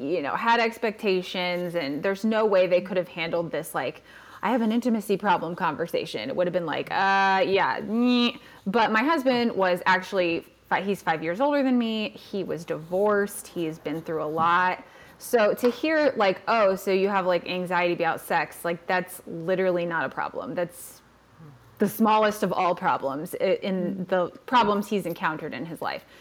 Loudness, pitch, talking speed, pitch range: -25 LUFS, 190 Hz, 185 wpm, 175-220 Hz